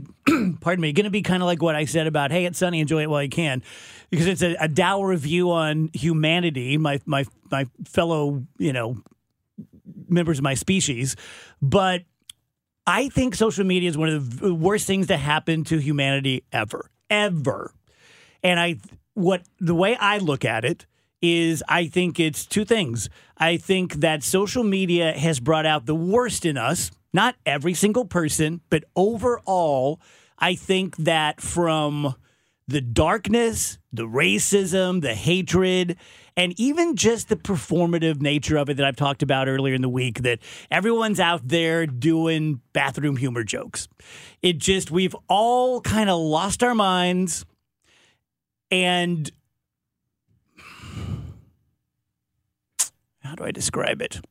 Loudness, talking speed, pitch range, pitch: -22 LUFS, 150 wpm, 150-185 Hz, 165 Hz